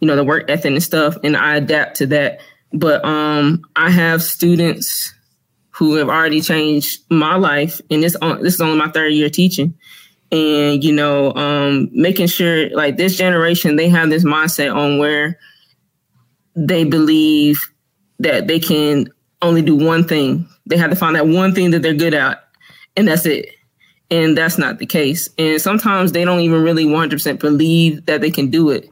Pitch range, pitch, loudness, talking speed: 150-170 Hz, 160 Hz, -14 LUFS, 185 wpm